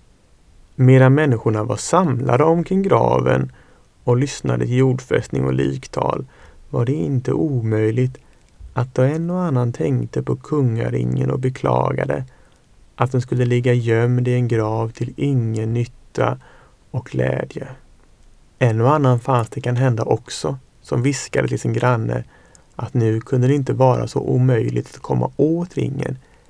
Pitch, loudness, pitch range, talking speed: 125 Hz, -19 LUFS, 110-130 Hz, 145 wpm